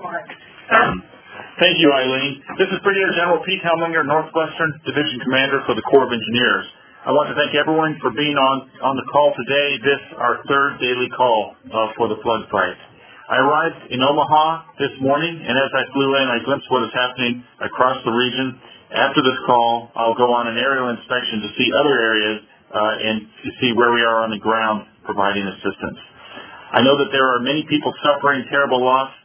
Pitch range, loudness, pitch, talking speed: 120-145 Hz, -18 LUFS, 130 Hz, 190 wpm